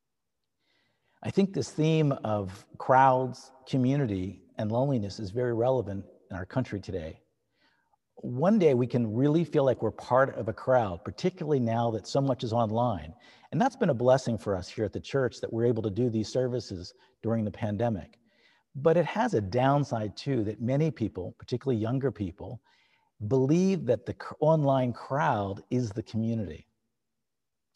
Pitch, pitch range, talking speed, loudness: 120 Hz, 110-135 Hz, 165 wpm, -28 LUFS